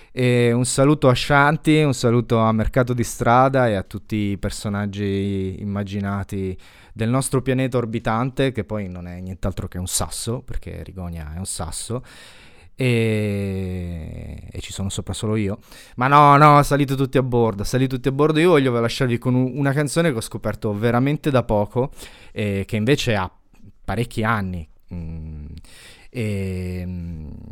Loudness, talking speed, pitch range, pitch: -20 LUFS, 160 wpm, 95-125 Hz, 110 Hz